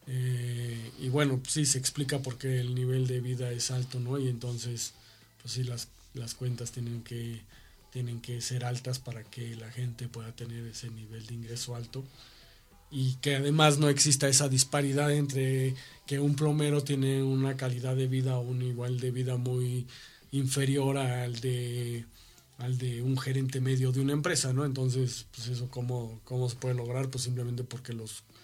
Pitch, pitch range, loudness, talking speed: 125 Hz, 120-130 Hz, -31 LUFS, 180 wpm